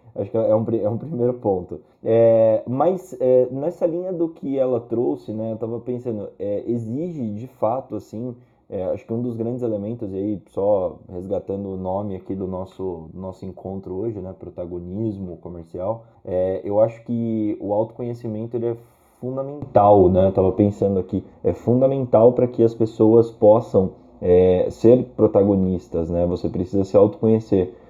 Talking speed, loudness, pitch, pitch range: 160 wpm, -21 LUFS, 110 Hz, 95-120 Hz